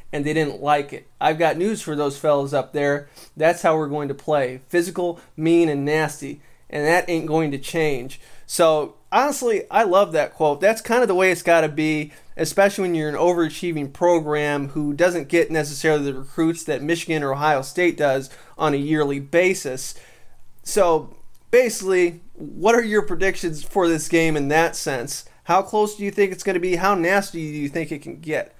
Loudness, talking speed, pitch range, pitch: -21 LUFS, 200 wpm, 145-175 Hz, 160 Hz